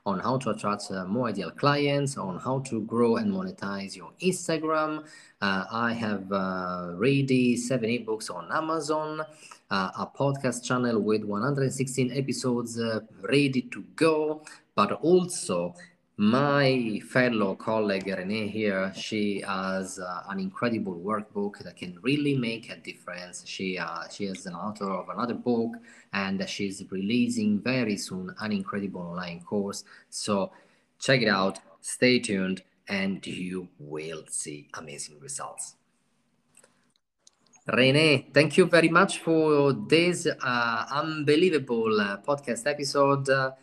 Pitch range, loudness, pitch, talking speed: 100-145 Hz, -27 LUFS, 120 Hz, 135 wpm